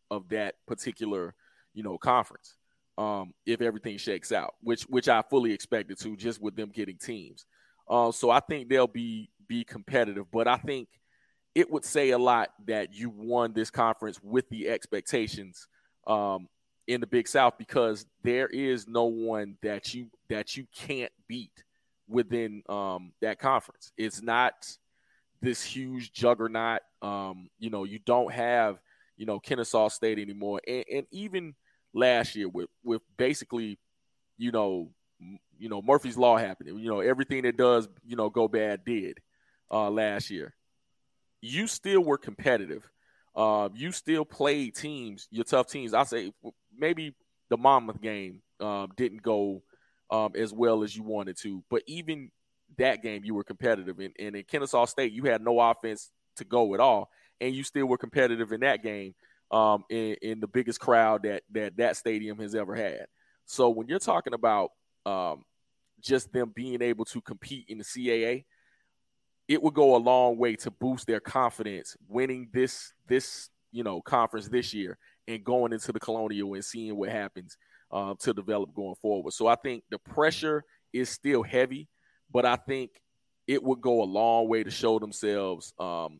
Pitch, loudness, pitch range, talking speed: 115 Hz, -29 LUFS, 105-125 Hz, 175 wpm